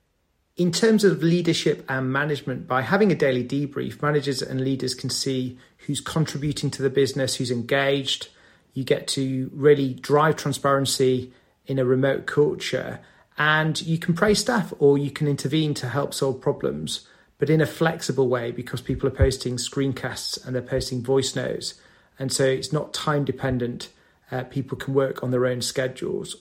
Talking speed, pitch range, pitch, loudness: 170 wpm, 130-145 Hz, 135 Hz, -23 LUFS